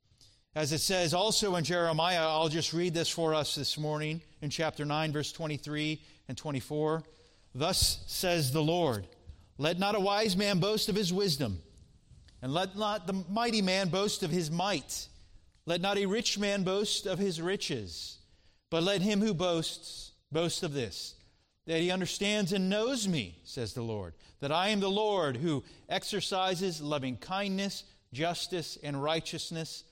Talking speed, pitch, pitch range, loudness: 165 wpm, 165 Hz, 140-195 Hz, -31 LUFS